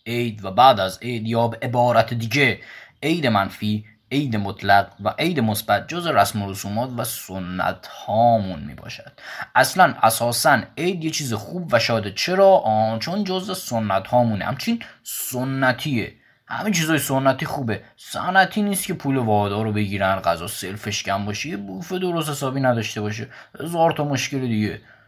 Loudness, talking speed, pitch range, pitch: -21 LUFS, 155 wpm, 105-145 Hz, 115 Hz